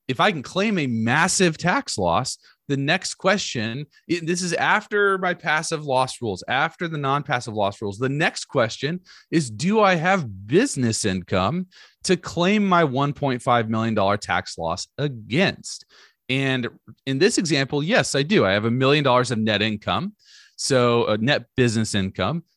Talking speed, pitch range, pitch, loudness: 160 wpm, 115-175 Hz, 135 Hz, -22 LUFS